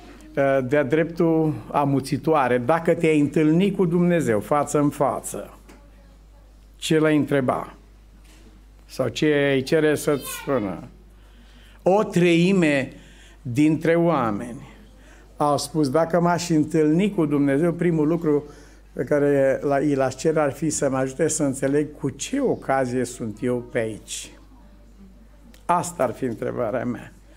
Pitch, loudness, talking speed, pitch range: 150 Hz, -22 LUFS, 125 wpm, 140-160 Hz